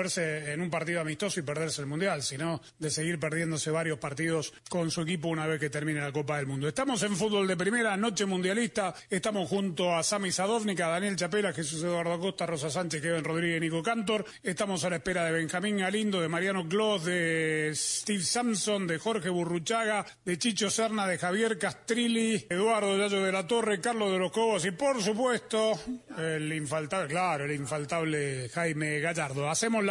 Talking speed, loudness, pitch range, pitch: 185 wpm, -30 LUFS, 160-210 Hz, 180 Hz